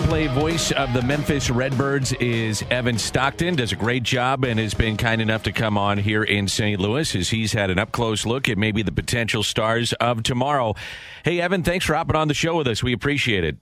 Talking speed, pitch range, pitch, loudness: 230 wpm, 110-140 Hz, 120 Hz, -21 LUFS